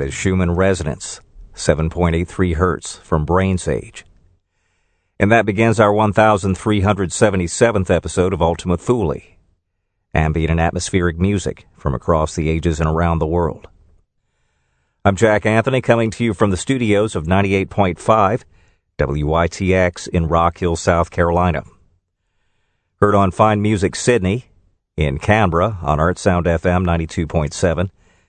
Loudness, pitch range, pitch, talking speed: -17 LUFS, 85-100 Hz, 90 Hz, 120 wpm